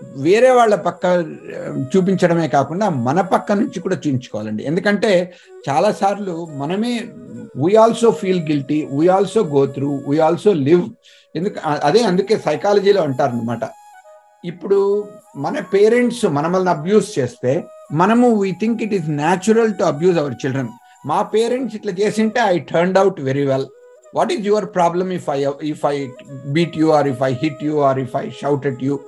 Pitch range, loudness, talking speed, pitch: 145-210 Hz, -17 LUFS, 155 wpm, 185 Hz